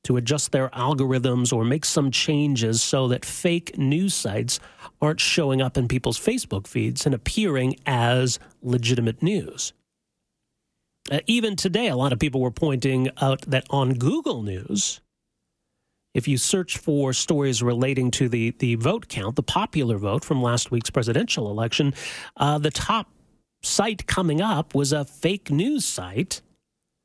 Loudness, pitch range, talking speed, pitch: -23 LUFS, 125-150 Hz, 155 wpm, 135 Hz